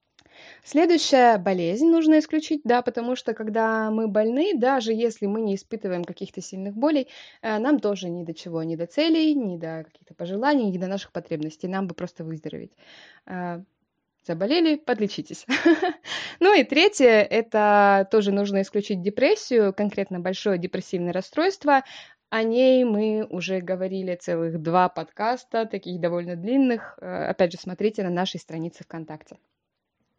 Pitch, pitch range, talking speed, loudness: 205 Hz, 180-250 Hz, 140 wpm, -23 LUFS